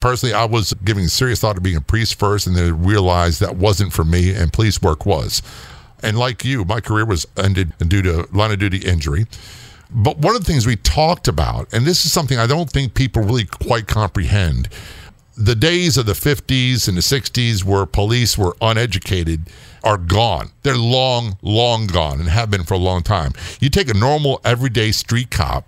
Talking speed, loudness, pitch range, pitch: 200 wpm, -17 LUFS, 95-120 Hz, 105 Hz